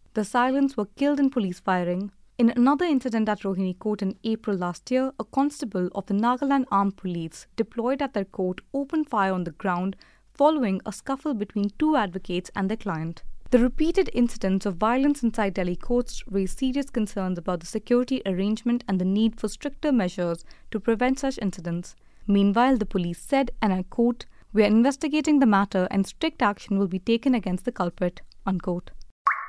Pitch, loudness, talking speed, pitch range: 215 Hz, -25 LUFS, 180 wpm, 190-255 Hz